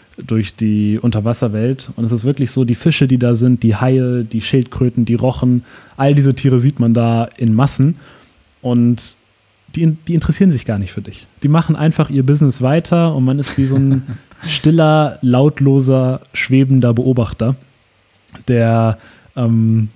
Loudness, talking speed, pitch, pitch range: -14 LUFS, 160 wpm, 125 Hz, 115-140 Hz